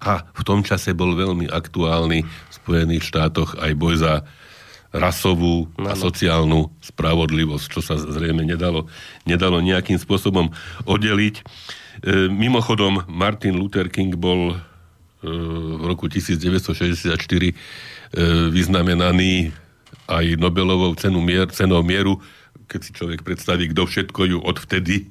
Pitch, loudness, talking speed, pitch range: 90 Hz, -20 LUFS, 120 wpm, 80-95 Hz